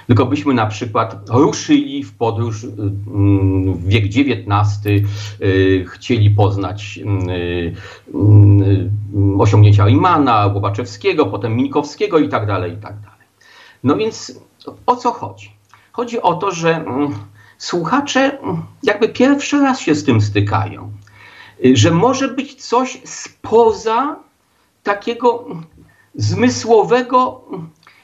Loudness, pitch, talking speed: -15 LUFS, 115 Hz, 100 wpm